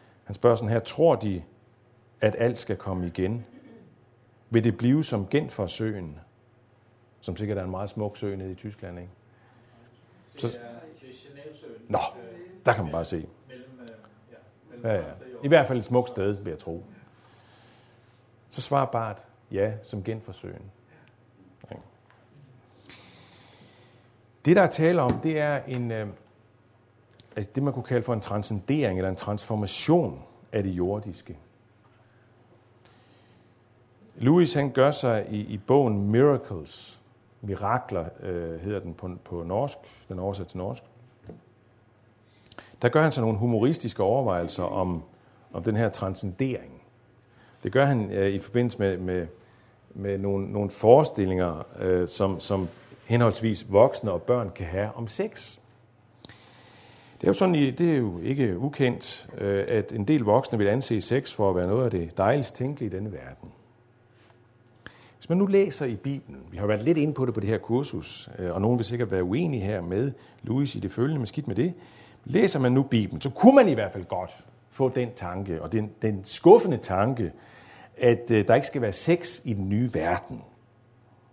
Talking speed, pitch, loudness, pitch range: 160 wpm, 120 Hz, -26 LUFS, 100-125 Hz